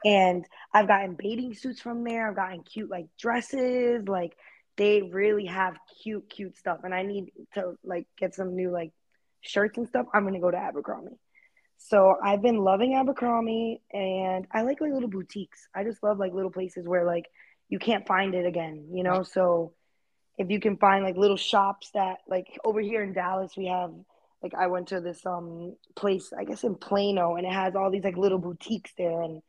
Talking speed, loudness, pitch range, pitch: 205 wpm, -27 LUFS, 180-210 Hz, 195 Hz